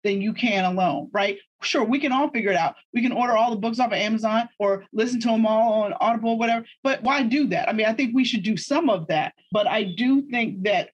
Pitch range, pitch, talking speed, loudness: 210-250 Hz, 230 Hz, 270 wpm, -23 LUFS